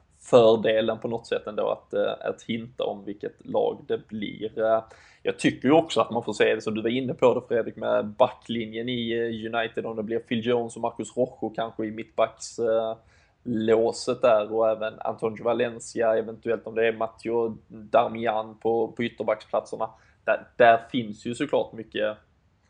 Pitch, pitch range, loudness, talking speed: 115 Hz, 110-120 Hz, -26 LUFS, 170 wpm